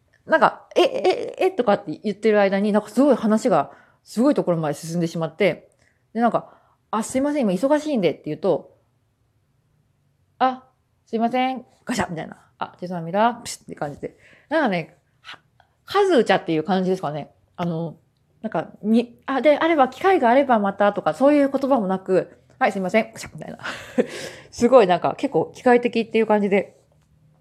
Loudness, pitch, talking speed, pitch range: -21 LUFS, 210 Hz, 365 characters per minute, 165-255 Hz